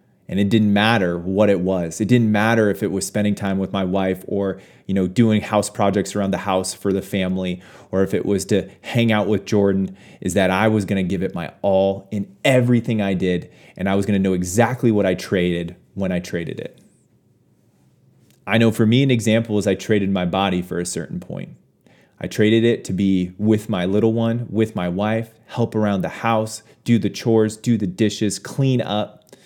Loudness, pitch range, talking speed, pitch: -20 LUFS, 95-110 Hz, 215 wpm, 100 Hz